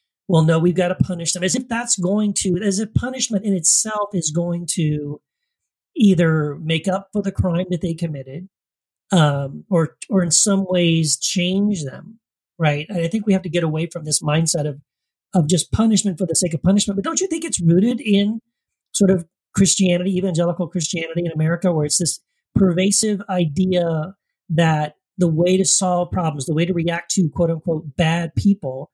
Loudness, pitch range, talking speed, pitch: -19 LUFS, 165-195 Hz, 190 wpm, 175 Hz